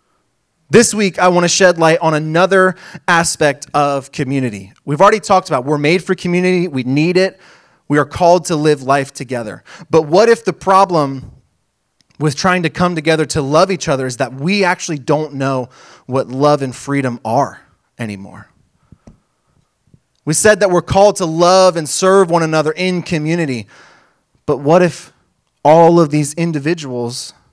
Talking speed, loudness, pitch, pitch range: 165 wpm, -13 LUFS, 160 Hz, 140-180 Hz